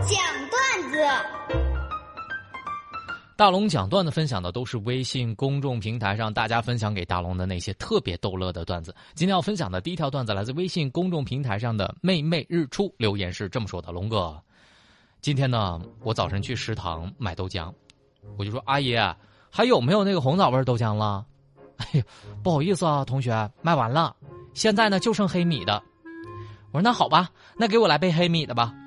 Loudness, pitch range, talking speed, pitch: -25 LUFS, 105-170 Hz, 280 characters per minute, 125 Hz